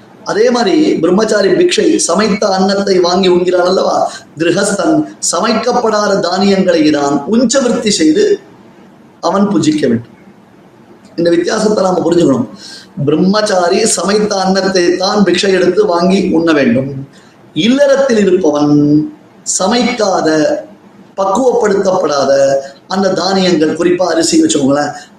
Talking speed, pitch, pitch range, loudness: 95 wpm, 185 Hz, 165-215 Hz, -11 LUFS